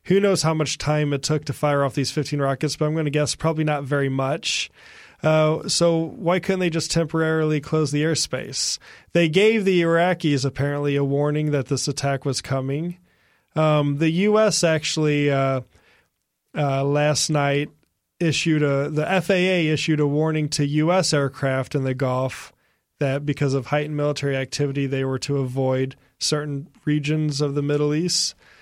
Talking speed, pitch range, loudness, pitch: 170 wpm, 140-160 Hz, -22 LUFS, 150 Hz